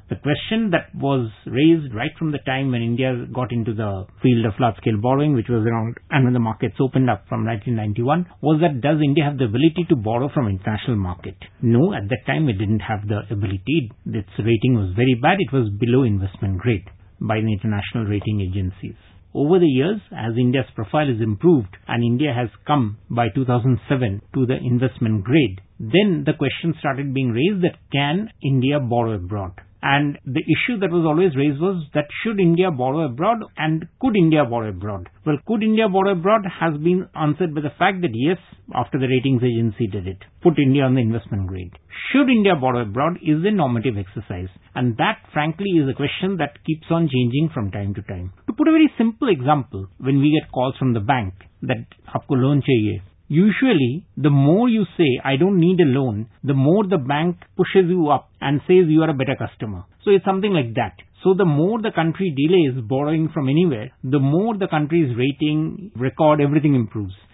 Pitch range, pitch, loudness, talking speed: 115-160 Hz, 135 Hz, -20 LUFS, 195 wpm